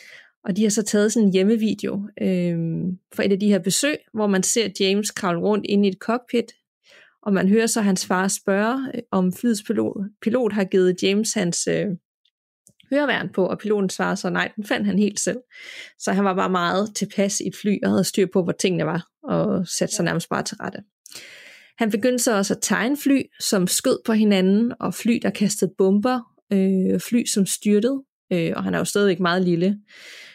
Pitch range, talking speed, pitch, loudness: 190-225 Hz, 205 wpm, 200 Hz, -21 LUFS